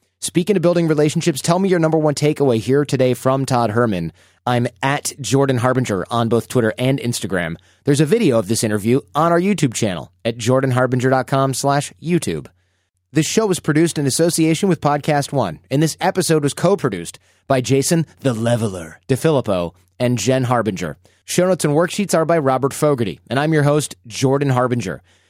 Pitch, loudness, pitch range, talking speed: 135 Hz, -18 LUFS, 115-155 Hz, 175 wpm